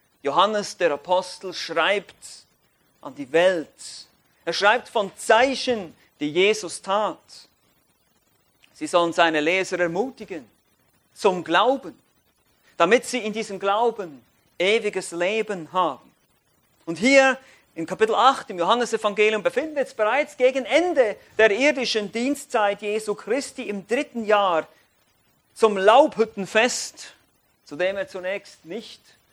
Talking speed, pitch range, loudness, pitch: 115 wpm, 190-255 Hz, -22 LUFS, 215 Hz